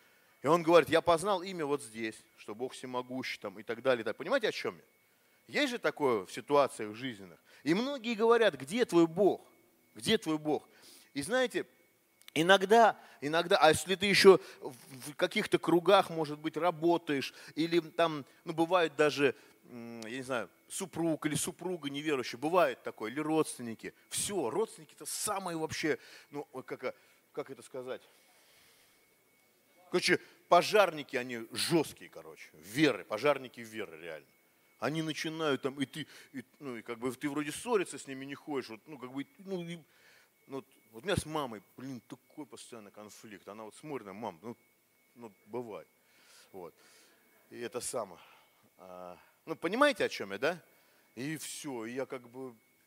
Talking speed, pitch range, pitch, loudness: 160 wpm, 125-175 Hz, 150 Hz, -32 LUFS